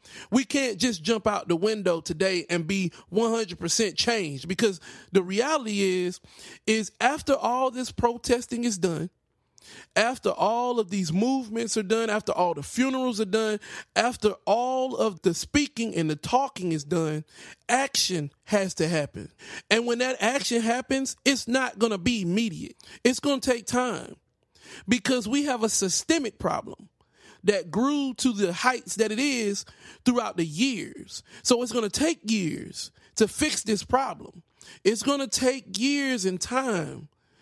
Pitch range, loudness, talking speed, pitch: 190-255 Hz, -26 LUFS, 155 wpm, 225 Hz